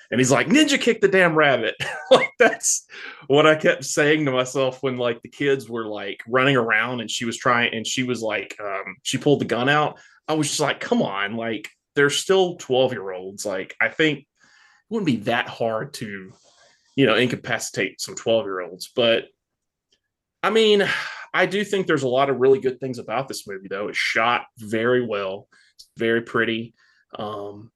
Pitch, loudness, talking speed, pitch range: 130 Hz, -21 LUFS, 190 wpm, 115-145 Hz